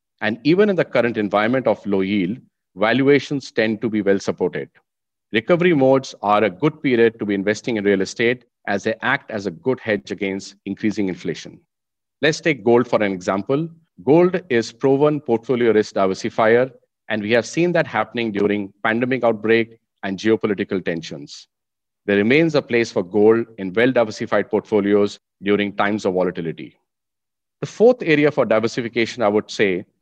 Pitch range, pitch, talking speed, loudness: 105-130 Hz, 110 Hz, 165 wpm, -19 LUFS